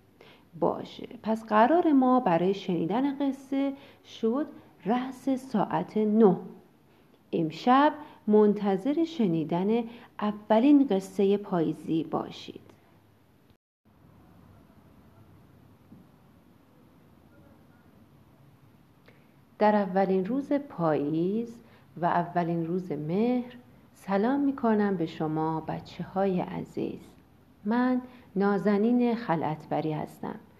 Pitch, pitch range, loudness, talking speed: 210 Hz, 175-245 Hz, -27 LUFS, 75 wpm